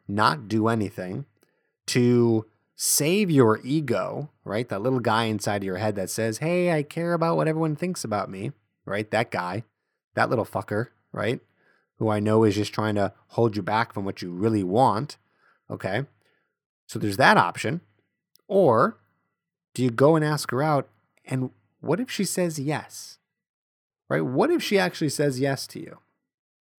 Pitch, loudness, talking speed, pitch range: 115 Hz, -24 LUFS, 170 wpm, 105-150 Hz